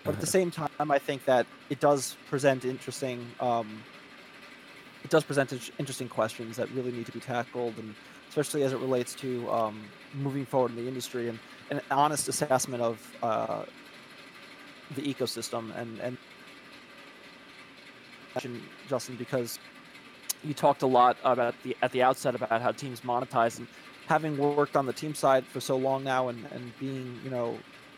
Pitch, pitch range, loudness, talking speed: 130 Hz, 120-140 Hz, -30 LUFS, 165 wpm